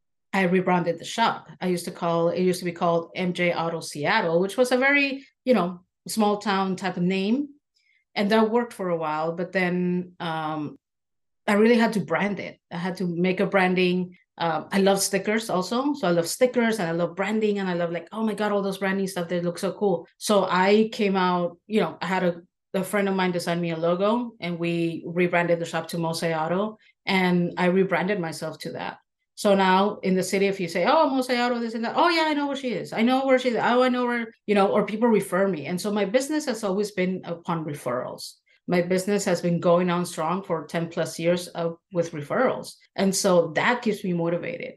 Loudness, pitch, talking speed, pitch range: -24 LUFS, 185 Hz, 230 wpm, 175-210 Hz